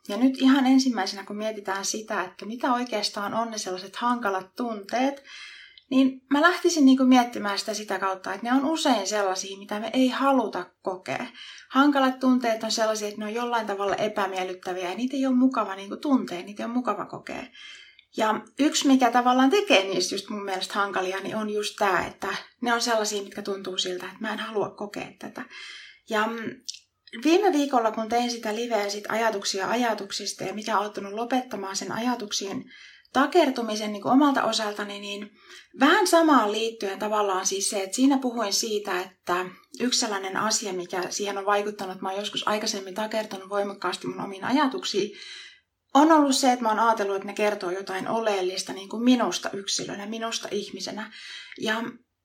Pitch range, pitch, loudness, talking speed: 200-255 Hz, 220 Hz, -25 LUFS, 170 wpm